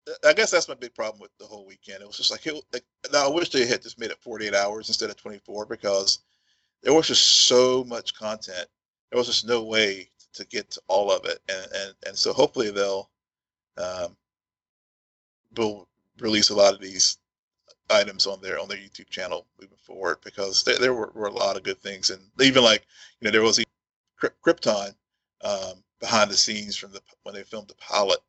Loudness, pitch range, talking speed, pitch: -23 LUFS, 100-125 Hz, 205 wpm, 105 Hz